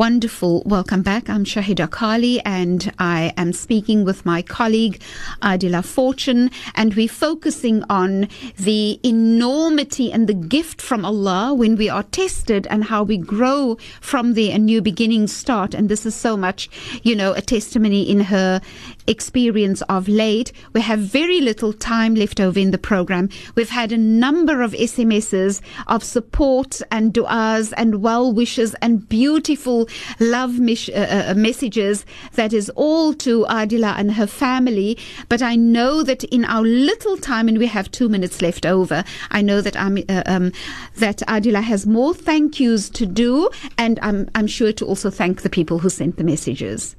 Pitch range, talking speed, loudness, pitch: 200-240 Hz, 170 wpm, -18 LUFS, 220 Hz